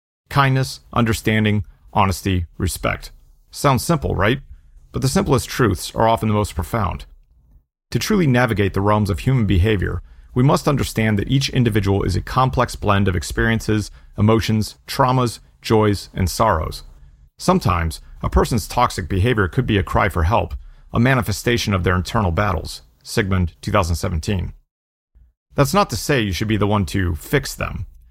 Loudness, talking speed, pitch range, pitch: -19 LUFS, 155 wpm, 85-115 Hz, 100 Hz